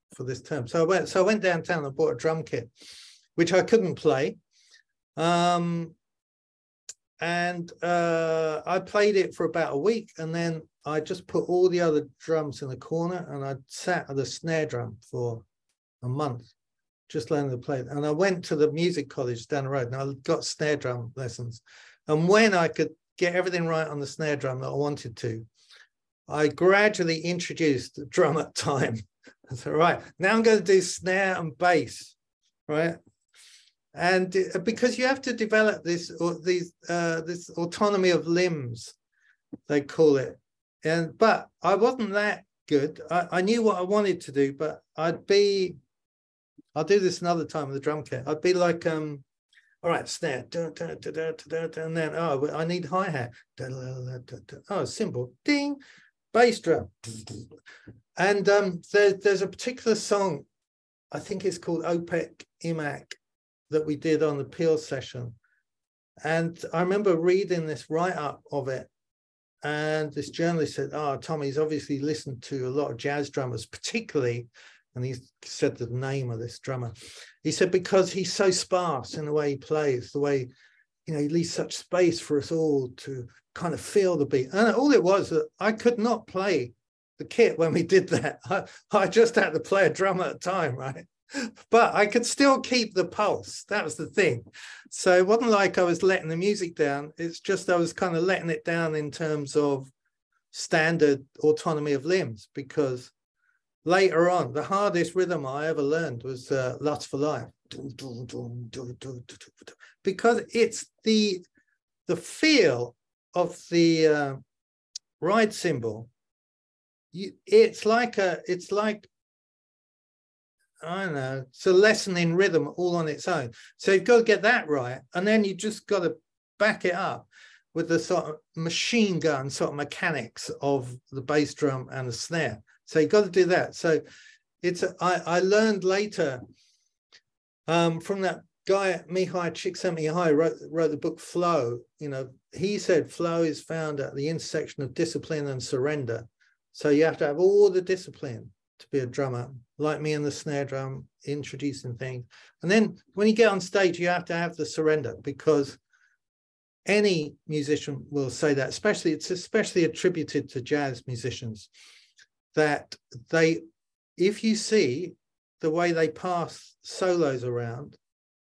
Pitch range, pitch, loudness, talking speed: 140-185 Hz, 160 Hz, -26 LUFS, 170 wpm